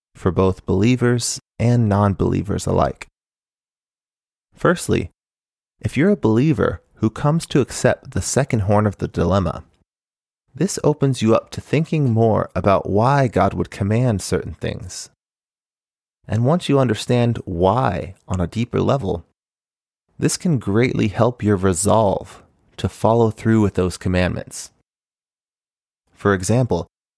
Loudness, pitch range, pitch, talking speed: -19 LUFS, 95-120 Hz, 110 Hz, 130 wpm